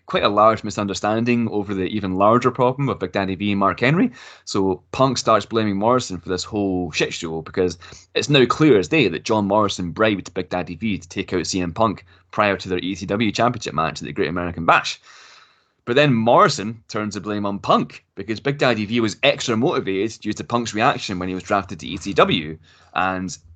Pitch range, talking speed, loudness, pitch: 95-110 Hz, 205 wpm, -20 LUFS, 100 Hz